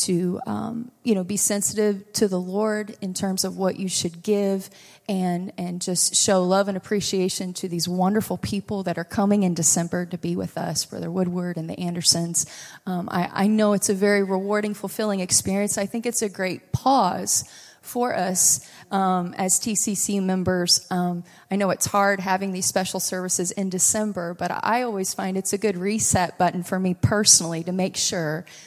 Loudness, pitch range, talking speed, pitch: -22 LUFS, 180-205 Hz, 185 wpm, 190 Hz